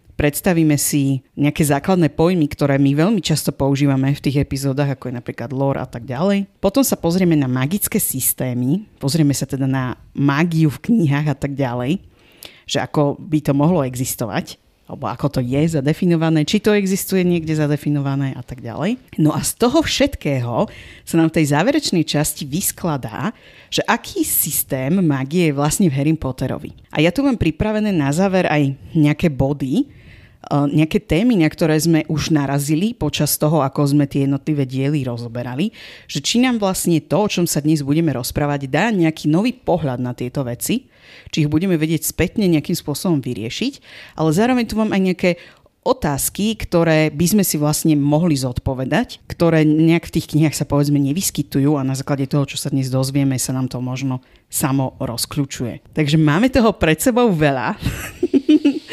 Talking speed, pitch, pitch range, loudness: 170 wpm, 150 Hz, 135-175 Hz, -18 LUFS